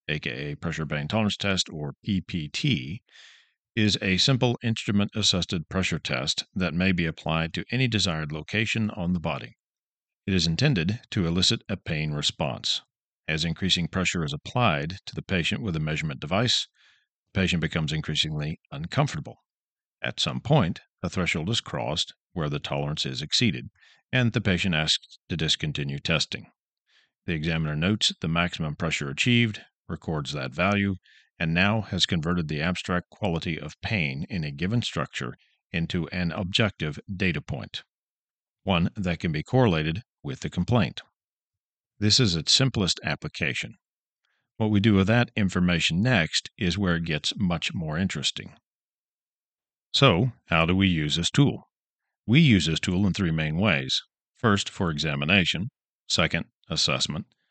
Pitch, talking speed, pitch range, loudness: 90 Hz, 150 wpm, 80-105 Hz, -25 LUFS